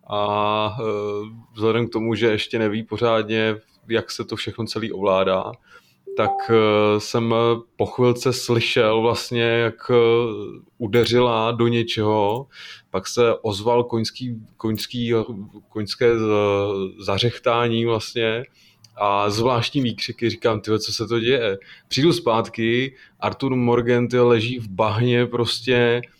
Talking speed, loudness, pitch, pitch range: 115 wpm, -21 LUFS, 115 Hz, 110-120 Hz